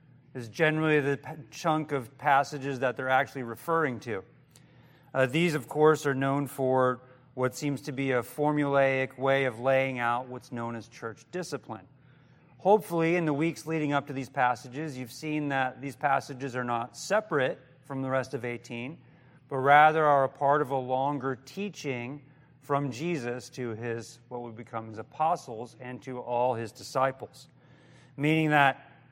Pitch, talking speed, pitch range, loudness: 135 Hz, 165 wpm, 125-150 Hz, -28 LUFS